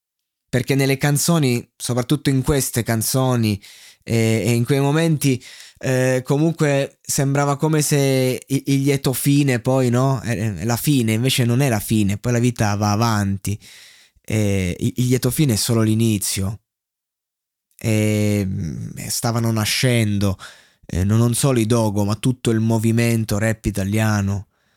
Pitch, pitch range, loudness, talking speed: 120 Hz, 110-135 Hz, -19 LUFS, 140 wpm